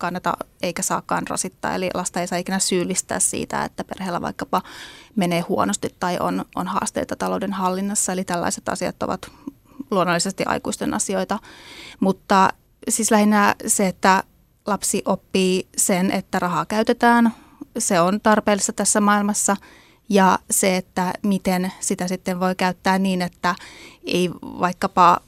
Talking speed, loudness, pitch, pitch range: 135 wpm, -21 LUFS, 190 Hz, 180-210 Hz